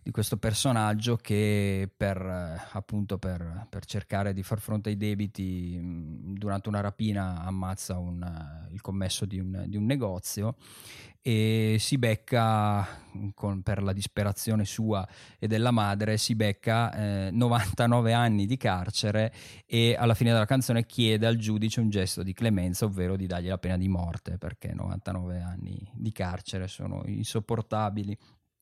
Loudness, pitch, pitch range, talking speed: -29 LUFS, 105 Hz, 95-110 Hz, 155 wpm